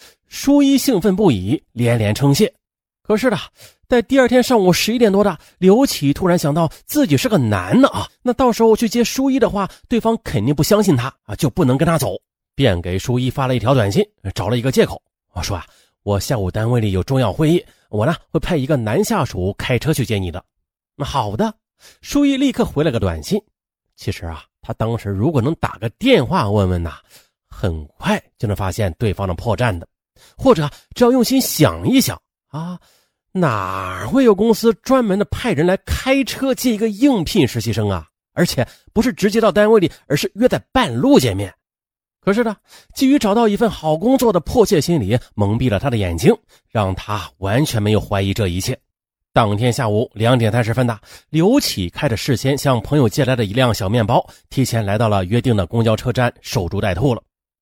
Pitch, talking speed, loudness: 135 Hz, 290 characters per minute, -17 LUFS